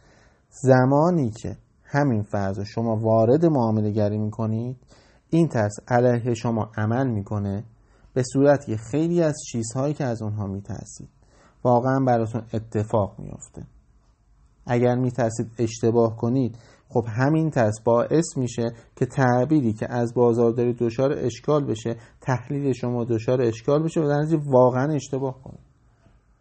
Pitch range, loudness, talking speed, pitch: 110-135 Hz, -23 LUFS, 130 wpm, 120 Hz